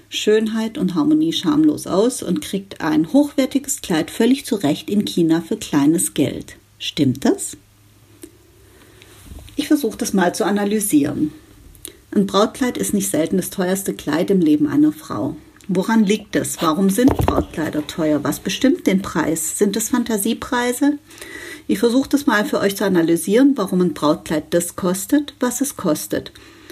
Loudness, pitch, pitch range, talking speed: -19 LUFS, 210 Hz, 170-270 Hz, 150 wpm